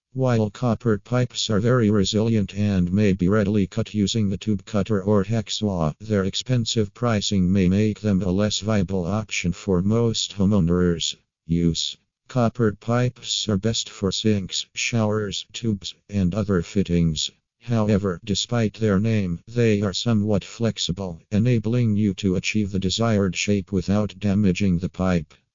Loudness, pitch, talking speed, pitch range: -22 LUFS, 105 Hz, 145 wpm, 95-110 Hz